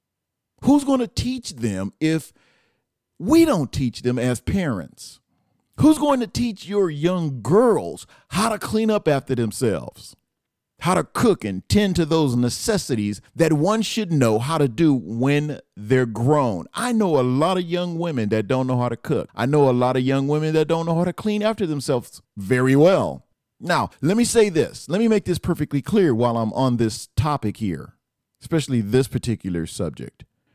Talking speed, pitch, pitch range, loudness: 185 wpm, 145 Hz, 120-180 Hz, -21 LUFS